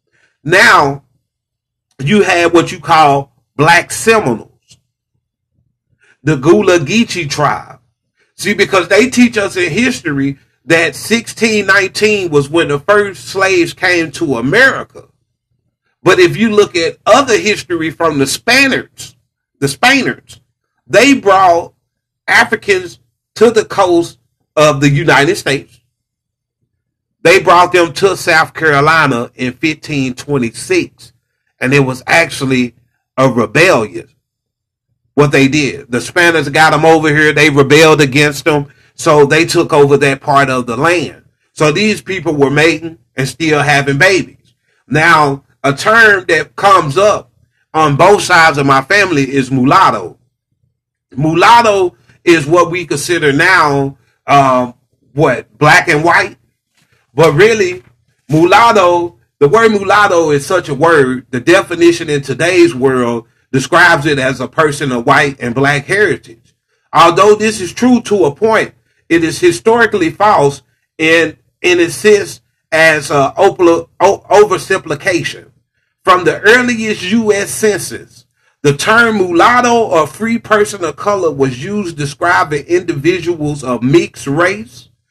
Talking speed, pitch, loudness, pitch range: 130 wpm, 155 Hz, -10 LUFS, 130-185 Hz